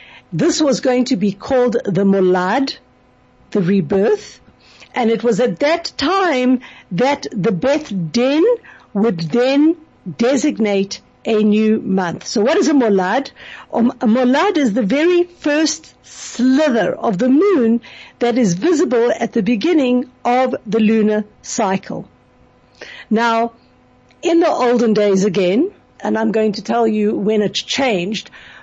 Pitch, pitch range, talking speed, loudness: 235 Hz, 210-275 Hz, 140 wpm, -16 LUFS